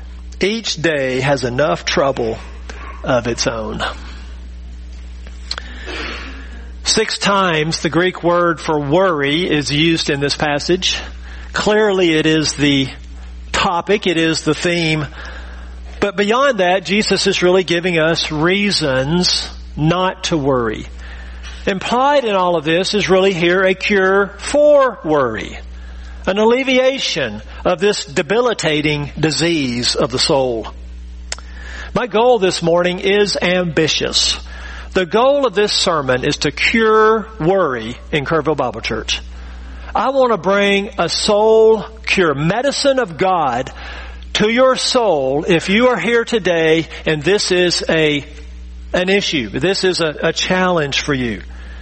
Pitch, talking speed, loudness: 160 Hz, 130 wpm, -15 LUFS